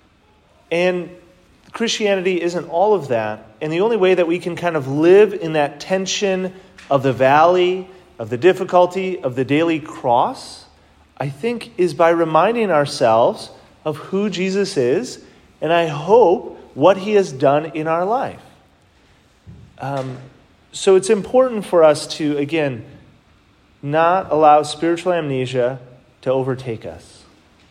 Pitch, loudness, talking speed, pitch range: 165 Hz, -17 LUFS, 140 wpm, 135-185 Hz